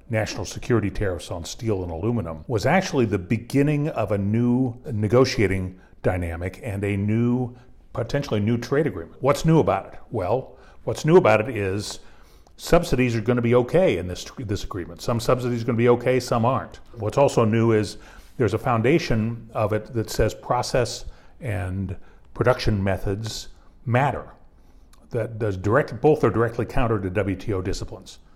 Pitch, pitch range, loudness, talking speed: 110 Hz, 100-125 Hz, -23 LUFS, 165 wpm